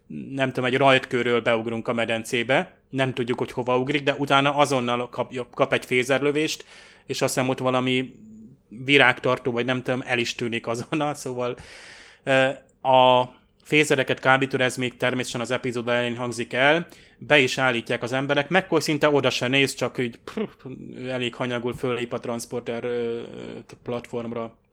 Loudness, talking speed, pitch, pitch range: -23 LUFS, 150 wpm, 125 Hz, 120-135 Hz